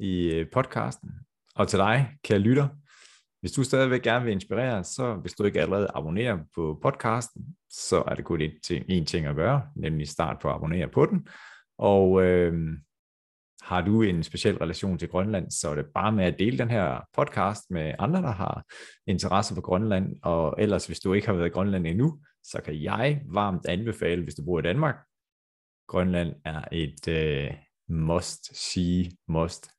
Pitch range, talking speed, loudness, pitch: 80-110 Hz, 175 wpm, -27 LUFS, 95 Hz